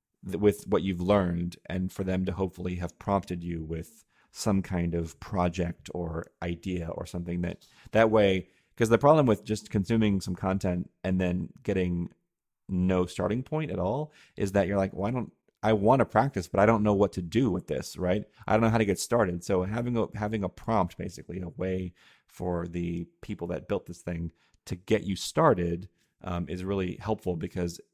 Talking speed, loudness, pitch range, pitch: 200 wpm, -29 LUFS, 90-105 Hz, 95 Hz